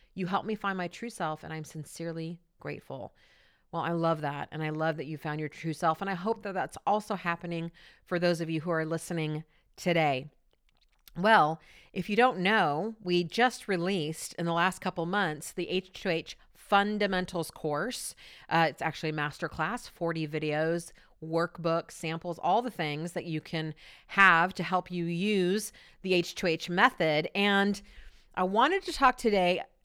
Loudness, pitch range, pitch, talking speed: -30 LUFS, 160-195 Hz, 170 Hz, 170 wpm